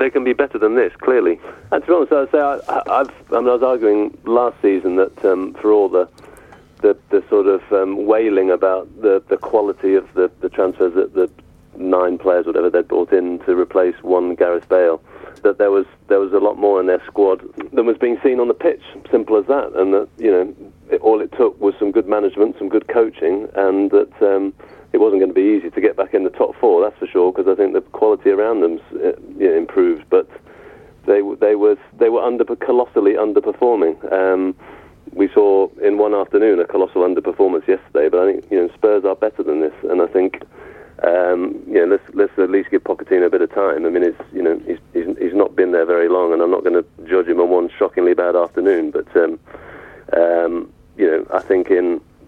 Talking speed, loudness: 225 wpm, -16 LUFS